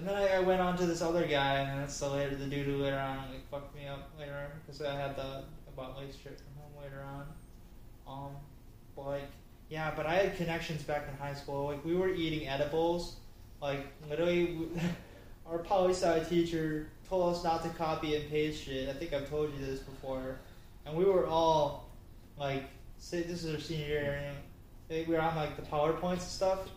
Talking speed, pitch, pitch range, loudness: 210 wpm, 145 Hz, 140-165 Hz, -34 LUFS